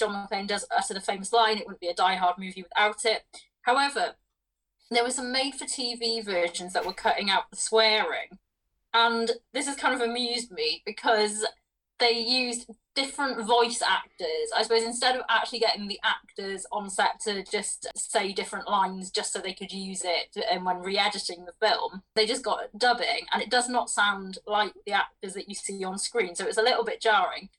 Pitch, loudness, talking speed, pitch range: 220 Hz, -27 LUFS, 195 wpm, 195-240 Hz